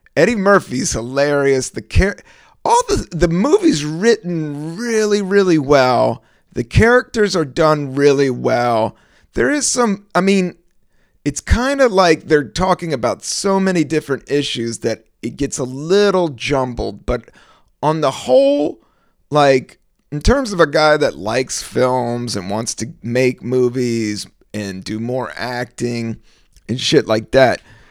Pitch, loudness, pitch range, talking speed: 145 Hz, -16 LUFS, 125-195 Hz, 145 wpm